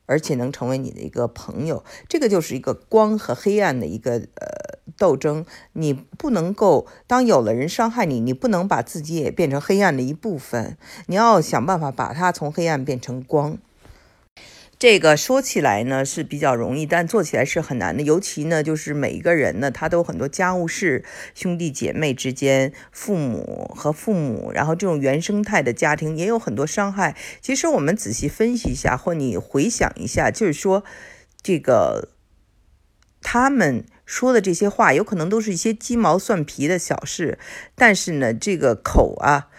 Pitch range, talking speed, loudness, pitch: 135-210 Hz, 270 characters per minute, -20 LUFS, 165 Hz